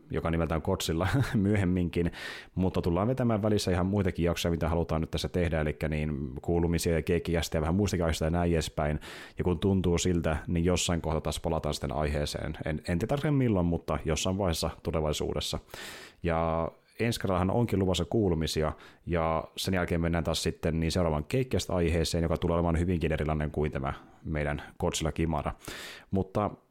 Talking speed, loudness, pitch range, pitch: 165 wpm, -30 LUFS, 80-90 Hz, 85 Hz